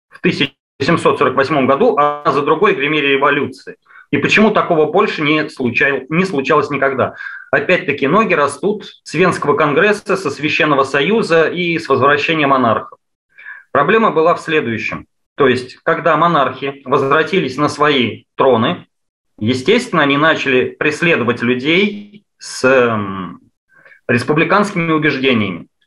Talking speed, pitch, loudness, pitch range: 120 wpm, 150 Hz, -14 LUFS, 135-170 Hz